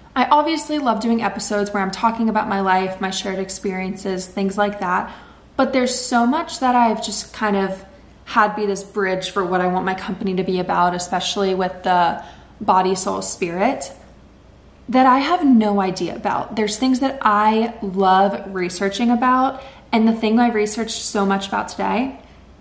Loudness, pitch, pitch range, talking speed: -19 LUFS, 205 Hz, 190-235 Hz, 180 wpm